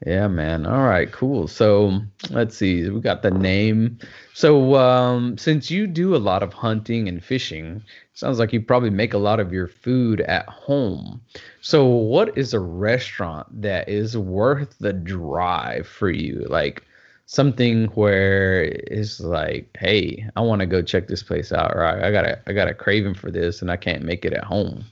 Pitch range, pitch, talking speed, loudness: 95-120 Hz, 105 Hz, 190 wpm, -21 LUFS